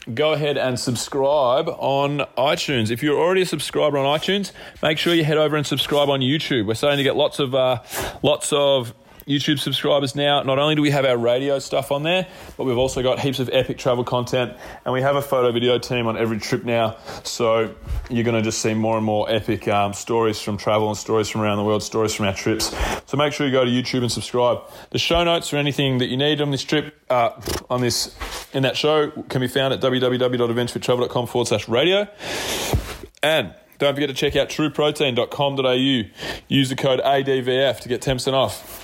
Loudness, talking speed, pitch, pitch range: -20 LUFS, 210 wpm, 130 Hz, 120-145 Hz